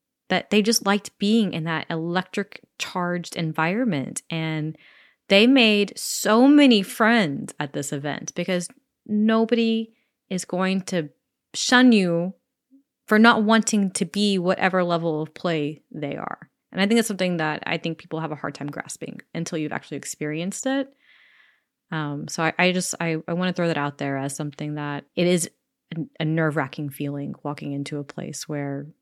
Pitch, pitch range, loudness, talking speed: 180 Hz, 155-215 Hz, -23 LUFS, 170 wpm